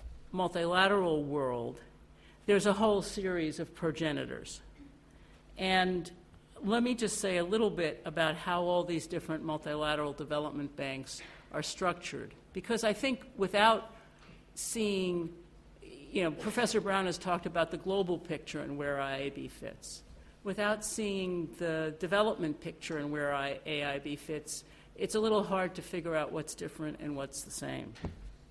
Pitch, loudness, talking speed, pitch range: 170 Hz, -34 LUFS, 140 wpm, 150-195 Hz